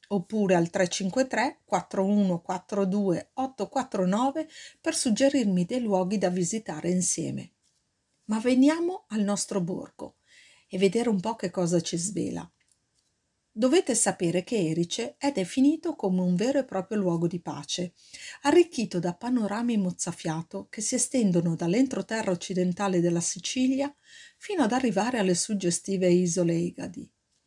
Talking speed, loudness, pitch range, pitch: 125 wpm, -27 LUFS, 180-250 Hz, 200 Hz